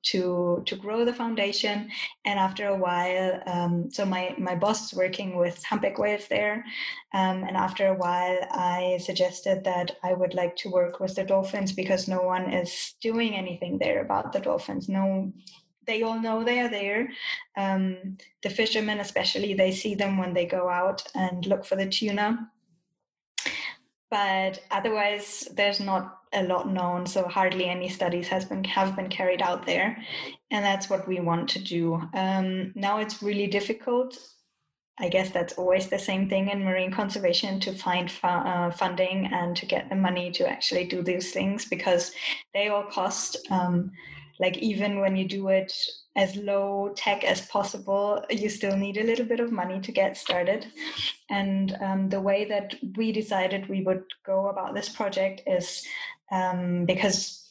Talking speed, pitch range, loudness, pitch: 175 wpm, 185-205 Hz, -27 LUFS, 195 Hz